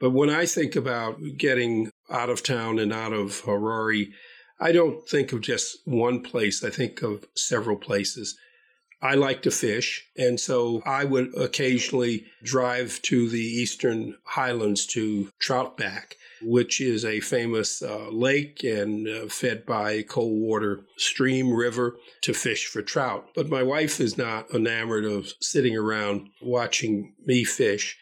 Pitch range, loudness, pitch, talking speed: 110-130 Hz, -25 LUFS, 120 Hz, 150 wpm